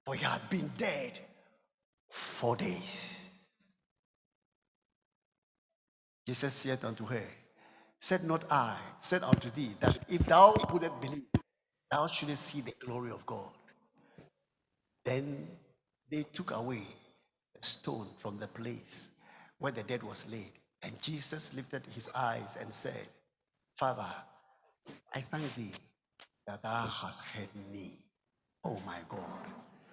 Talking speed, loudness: 125 wpm, -35 LUFS